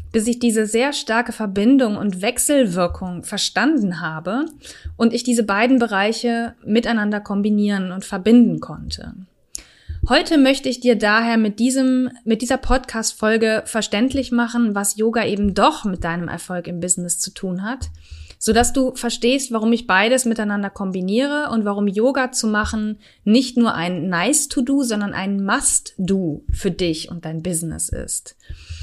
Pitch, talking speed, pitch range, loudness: 220 Hz, 155 wpm, 195-245 Hz, -19 LUFS